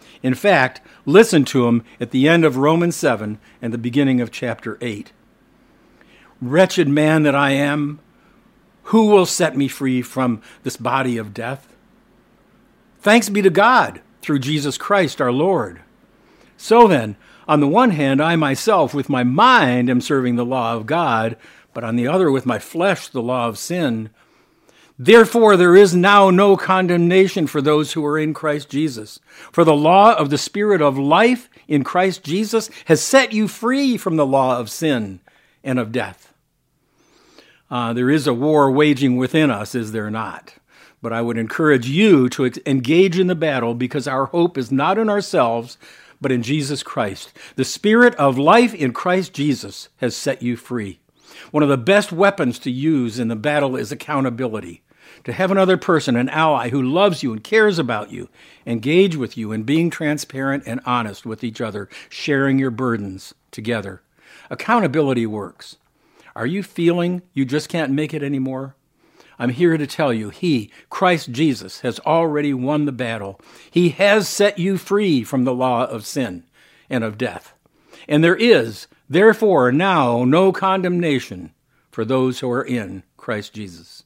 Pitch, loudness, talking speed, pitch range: 145 Hz, -17 LUFS, 170 wpm, 125-175 Hz